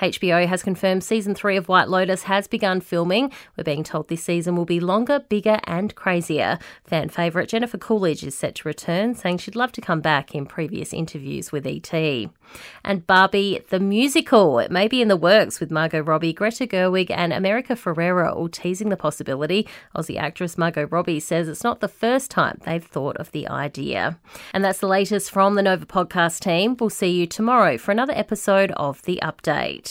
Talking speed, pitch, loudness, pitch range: 195 wpm, 185 Hz, -21 LUFS, 165-205 Hz